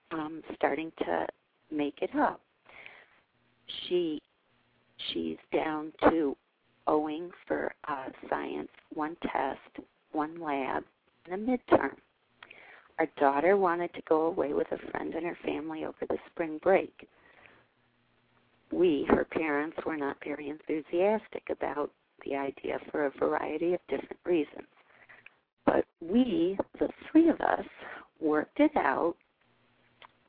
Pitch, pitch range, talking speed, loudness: 160 Hz, 150-220 Hz, 125 wpm, -31 LUFS